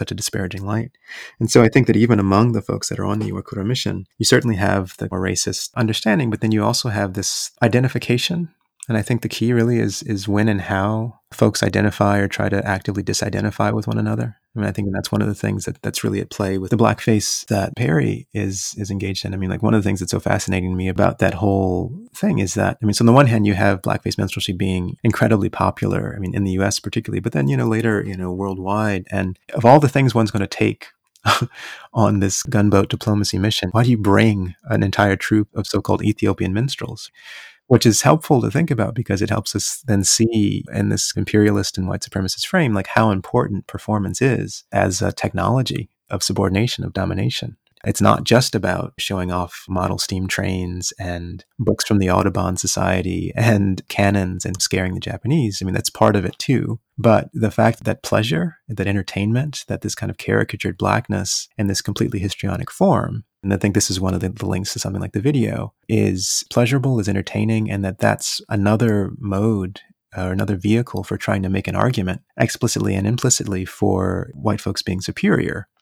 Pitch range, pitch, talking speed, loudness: 95-115 Hz, 105 Hz, 210 wpm, -19 LUFS